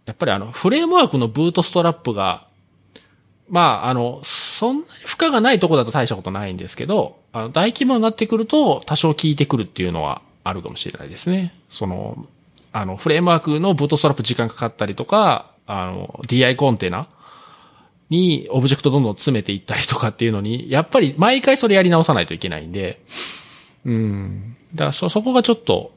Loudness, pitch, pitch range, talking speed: -19 LUFS, 140 Hz, 115-175 Hz, 425 characters per minute